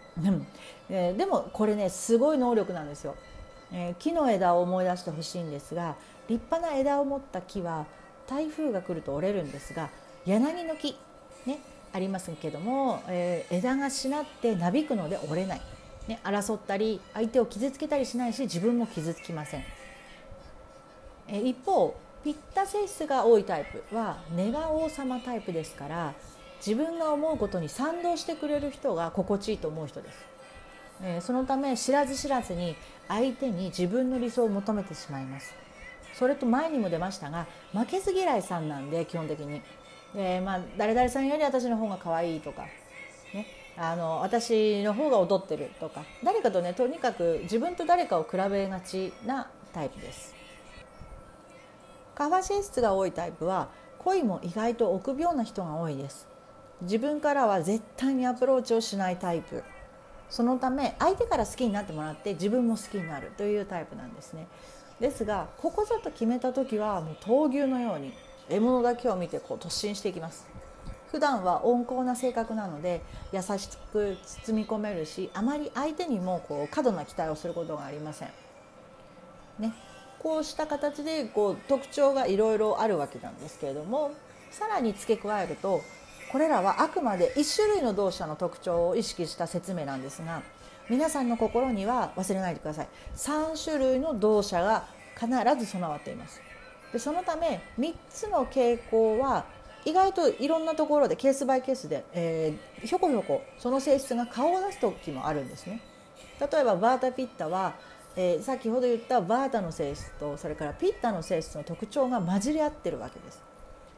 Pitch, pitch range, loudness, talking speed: 230 Hz, 180-270 Hz, -29 LUFS, 340 characters per minute